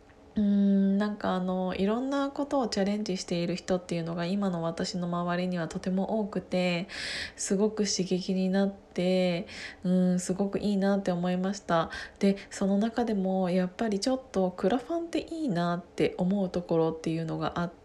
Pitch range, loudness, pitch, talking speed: 180-205 Hz, -29 LUFS, 190 Hz, 365 characters per minute